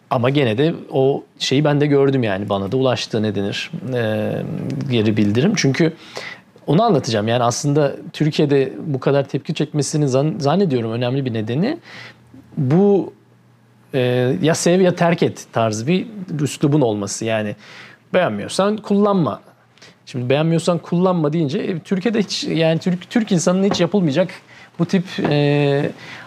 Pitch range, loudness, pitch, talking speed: 125-180 Hz, -18 LUFS, 145 Hz, 140 wpm